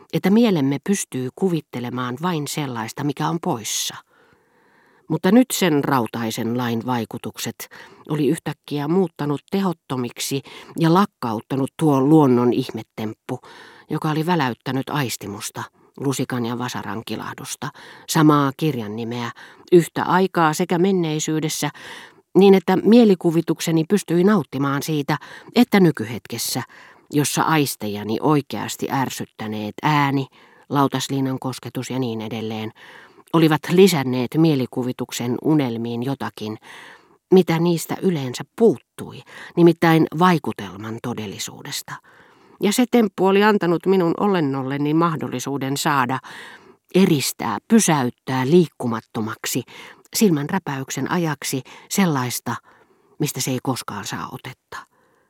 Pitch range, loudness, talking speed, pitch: 125-170 Hz, -20 LUFS, 100 wpm, 145 Hz